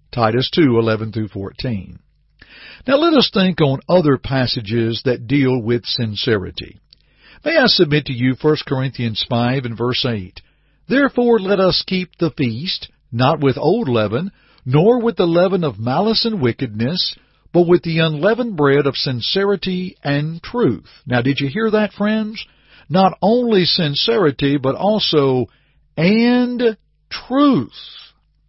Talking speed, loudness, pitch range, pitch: 135 wpm, -17 LUFS, 125-195 Hz, 150 Hz